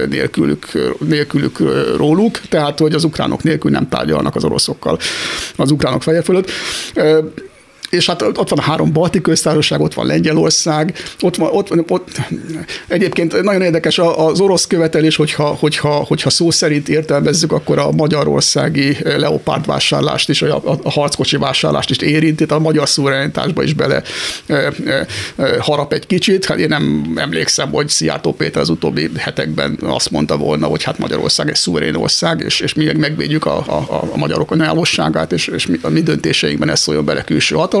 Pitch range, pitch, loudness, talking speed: 145-165 Hz, 155 Hz, -14 LUFS, 170 wpm